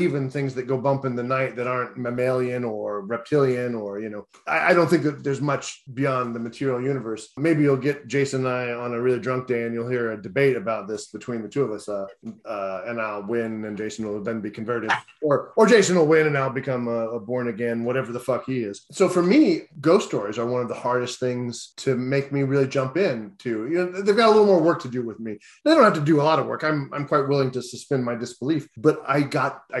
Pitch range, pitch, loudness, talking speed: 115-140 Hz, 125 Hz, -23 LUFS, 260 wpm